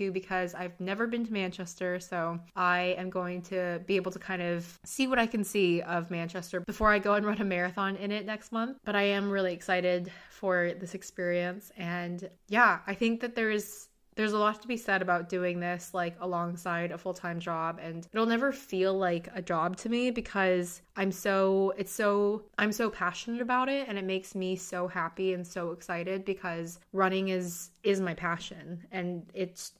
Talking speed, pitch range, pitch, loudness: 200 wpm, 175-205 Hz, 185 Hz, -31 LUFS